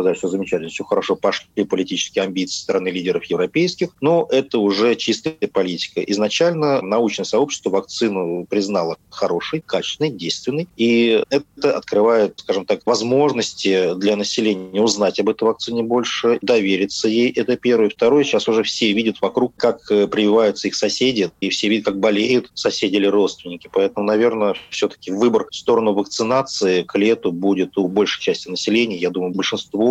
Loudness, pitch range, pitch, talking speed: -19 LUFS, 100-125 Hz, 105 Hz, 155 wpm